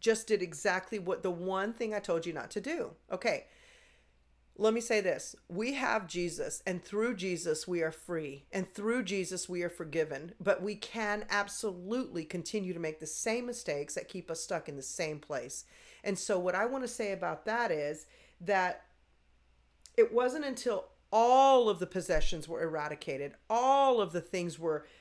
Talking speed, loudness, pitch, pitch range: 180 wpm, -33 LUFS, 185 Hz, 165-220 Hz